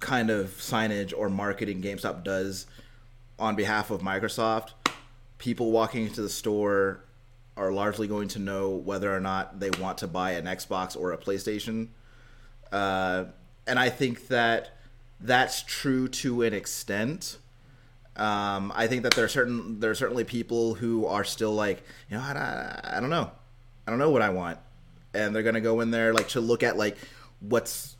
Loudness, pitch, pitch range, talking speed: -28 LUFS, 110 Hz, 100-120 Hz, 175 wpm